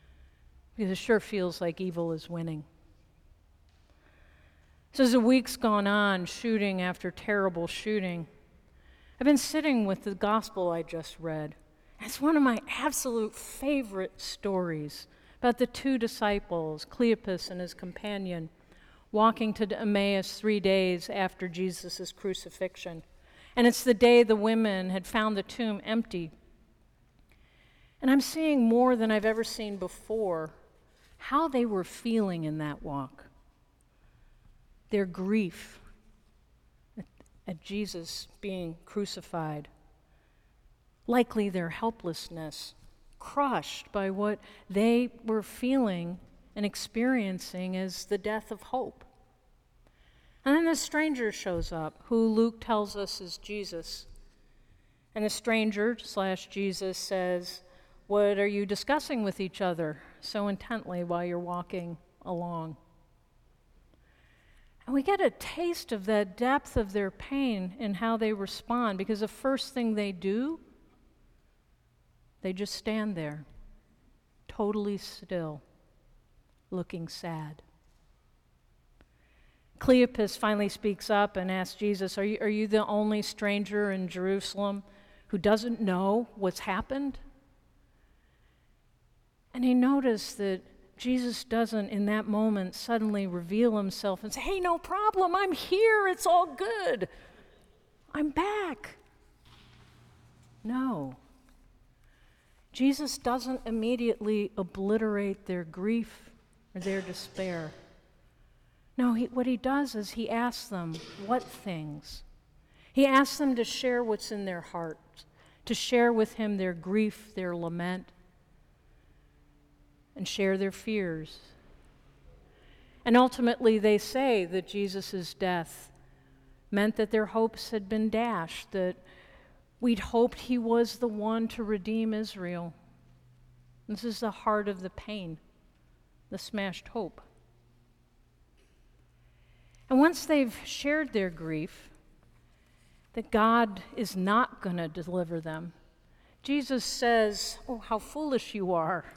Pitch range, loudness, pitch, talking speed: 175-230 Hz, -30 LUFS, 205 Hz, 120 wpm